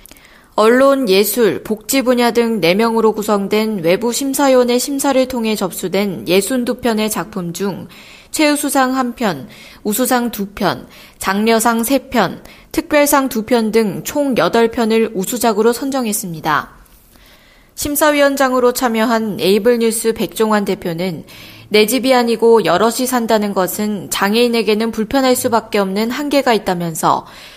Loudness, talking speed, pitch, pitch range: -15 LUFS, 270 characters per minute, 225 Hz, 205-250 Hz